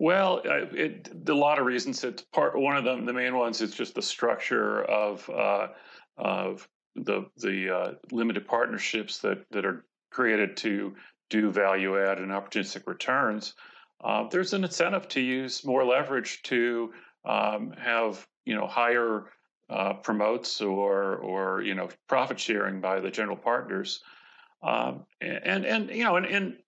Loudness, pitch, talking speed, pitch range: -28 LUFS, 115 Hz, 160 wpm, 100-130 Hz